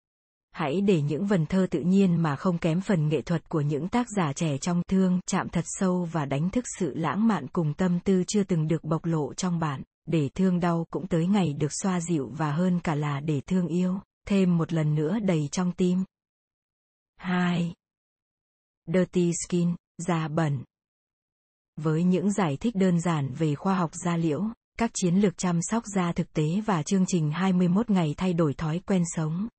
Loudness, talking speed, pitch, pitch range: -26 LUFS, 195 wpm, 175 Hz, 160-185 Hz